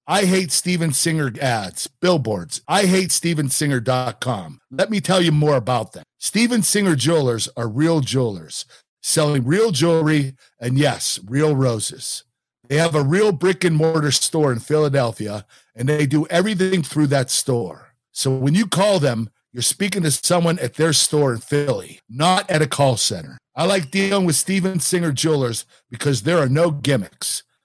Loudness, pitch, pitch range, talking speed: -18 LUFS, 150 Hz, 130-175 Hz, 165 wpm